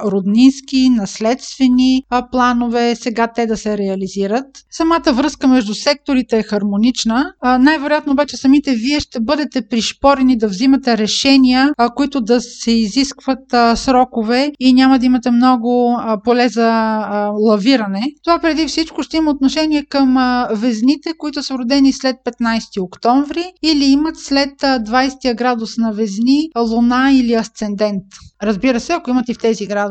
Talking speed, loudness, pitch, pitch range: 155 wpm, -15 LUFS, 255 Hz, 230-275 Hz